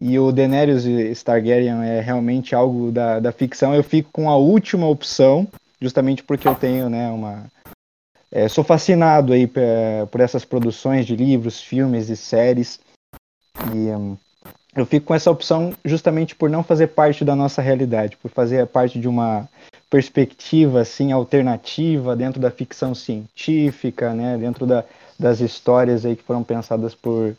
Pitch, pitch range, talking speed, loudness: 125 Hz, 120-140 Hz, 155 wpm, -18 LUFS